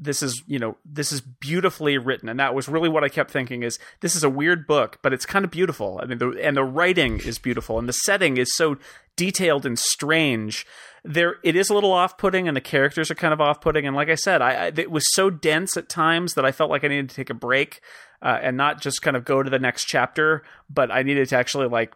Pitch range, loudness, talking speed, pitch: 135-165 Hz, -22 LUFS, 265 wpm, 145 Hz